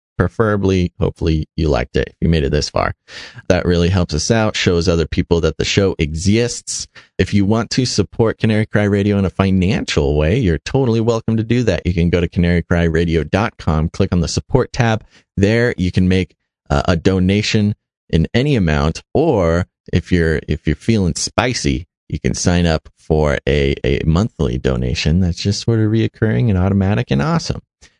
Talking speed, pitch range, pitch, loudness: 185 wpm, 80-110 Hz, 90 Hz, -17 LUFS